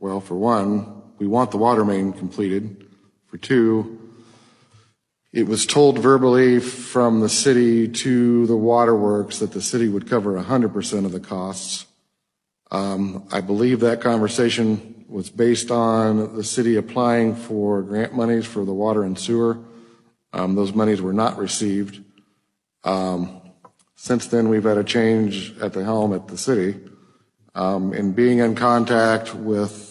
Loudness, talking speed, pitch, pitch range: -20 LUFS, 150 wpm, 110 Hz, 100-115 Hz